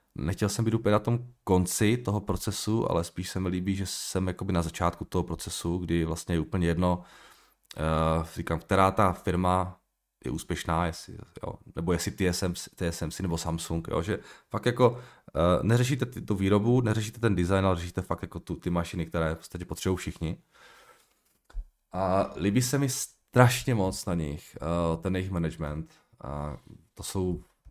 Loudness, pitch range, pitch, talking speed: -29 LUFS, 85-105 Hz, 90 Hz, 175 wpm